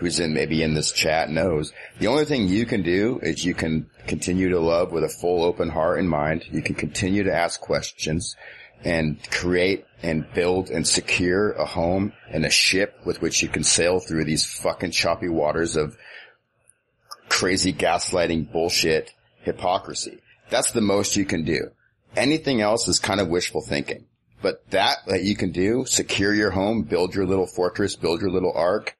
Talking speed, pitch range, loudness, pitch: 180 wpm, 80-95 Hz, -22 LUFS, 90 Hz